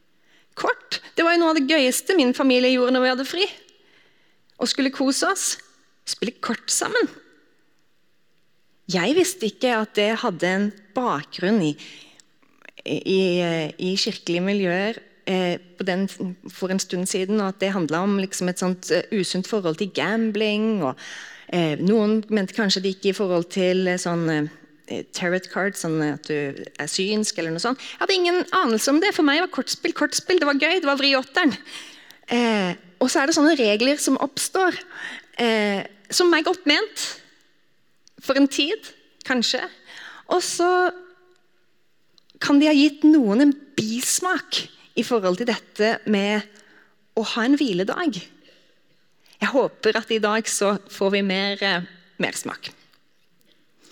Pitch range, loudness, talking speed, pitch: 190-290 Hz, -22 LUFS, 155 wpm, 220 Hz